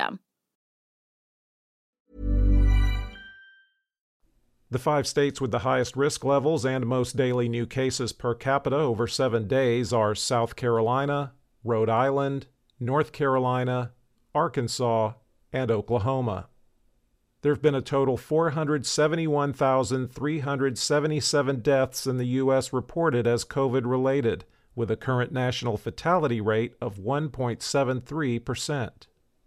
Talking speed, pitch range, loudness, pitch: 100 wpm, 120-140 Hz, -26 LUFS, 130 Hz